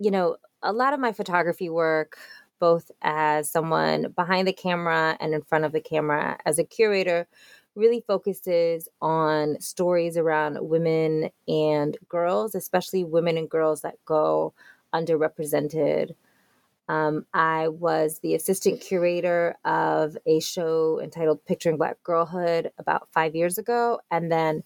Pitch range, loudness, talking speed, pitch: 155-180 Hz, -24 LUFS, 140 wpm, 165 Hz